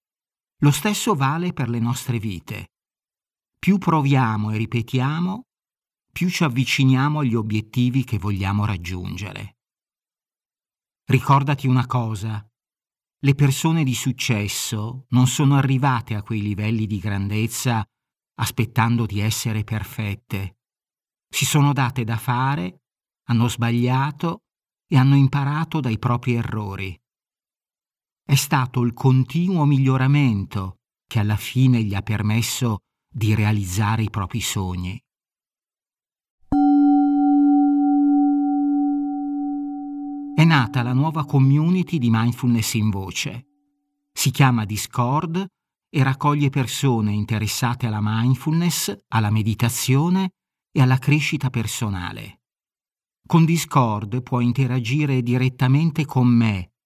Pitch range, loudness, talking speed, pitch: 110-150 Hz, -21 LUFS, 105 wpm, 130 Hz